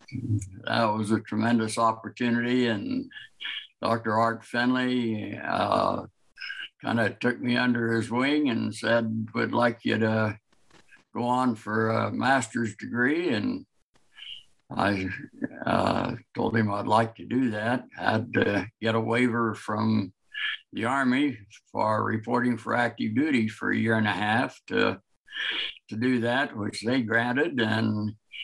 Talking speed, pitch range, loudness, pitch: 145 wpm, 110-120 Hz, -27 LUFS, 115 Hz